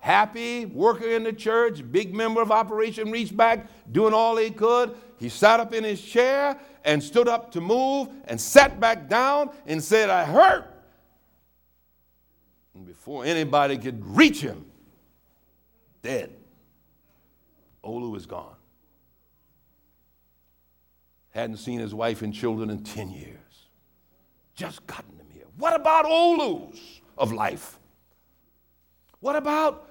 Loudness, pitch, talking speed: -23 LUFS, 165 Hz, 130 wpm